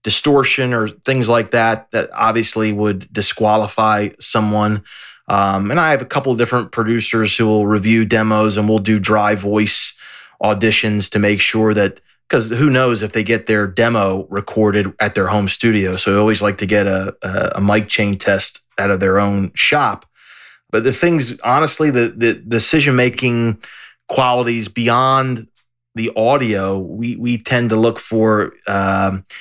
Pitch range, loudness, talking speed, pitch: 105-120 Hz, -15 LUFS, 165 wpm, 110 Hz